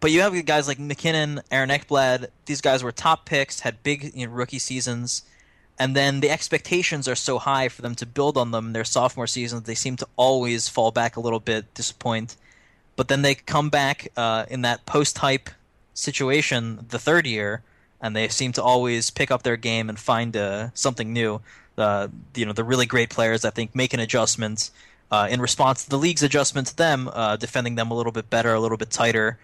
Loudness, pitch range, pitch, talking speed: -23 LUFS, 115-140 Hz, 125 Hz, 215 wpm